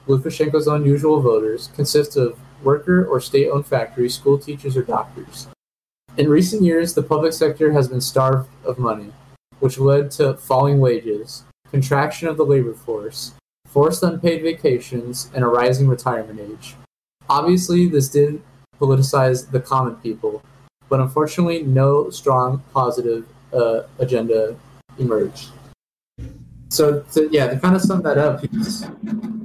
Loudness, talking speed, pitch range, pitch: -18 LUFS, 135 wpm, 125-150 Hz, 135 Hz